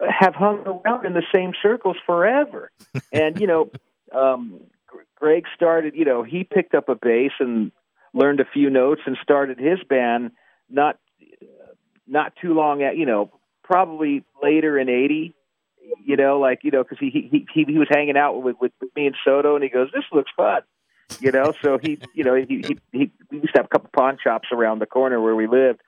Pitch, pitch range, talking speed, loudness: 150 Hz, 130-185 Hz, 205 wpm, -20 LUFS